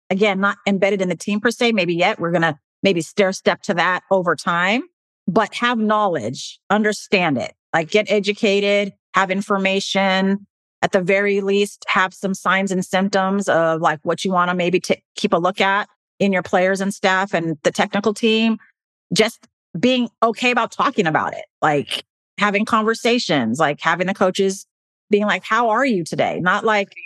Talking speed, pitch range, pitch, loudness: 180 wpm, 185-215 Hz, 200 Hz, -19 LUFS